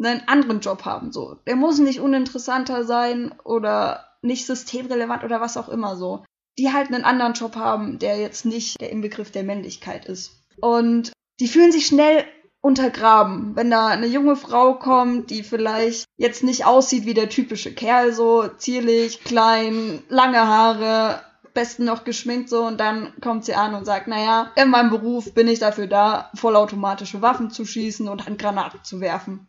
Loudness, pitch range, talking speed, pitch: -20 LUFS, 220-250 Hz, 175 wpm, 230 Hz